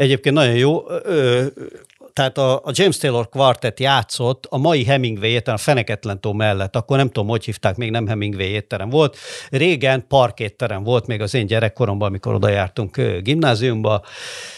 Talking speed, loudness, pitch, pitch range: 150 wpm, -18 LUFS, 120 Hz, 110-135 Hz